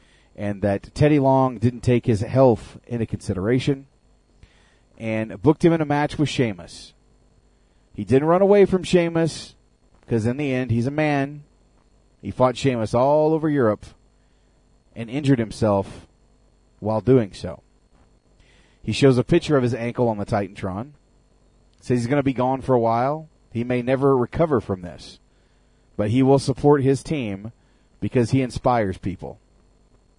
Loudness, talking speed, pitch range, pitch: -21 LUFS, 155 wpm, 105-140 Hz, 125 Hz